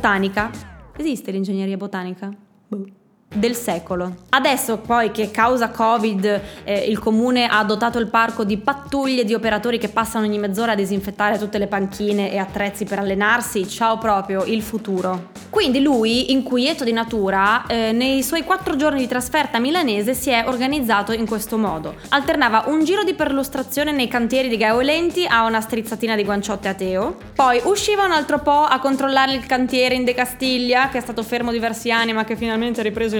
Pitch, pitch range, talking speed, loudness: 230 Hz, 210-260 Hz, 175 wpm, -19 LUFS